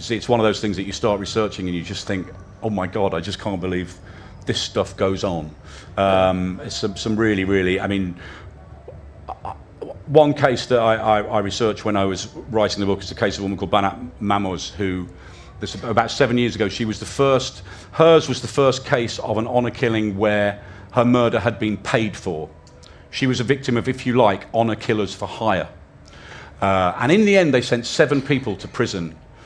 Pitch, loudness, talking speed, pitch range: 105 Hz, -20 LUFS, 210 wpm, 95-120 Hz